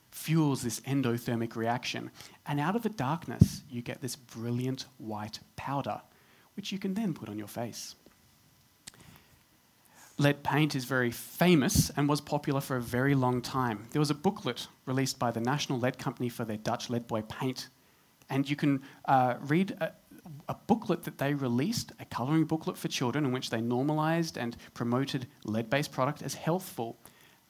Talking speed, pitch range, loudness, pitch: 170 wpm, 120-150 Hz, -31 LUFS, 130 Hz